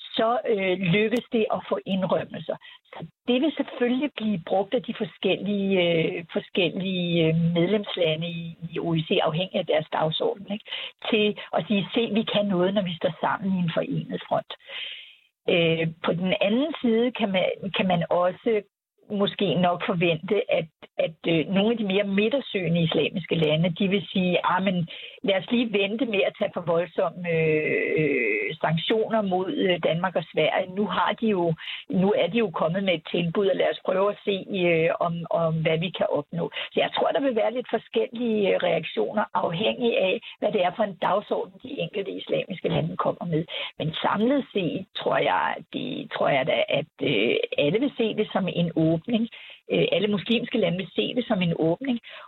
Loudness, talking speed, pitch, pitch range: -25 LUFS, 180 wpm, 200 Hz, 175-225 Hz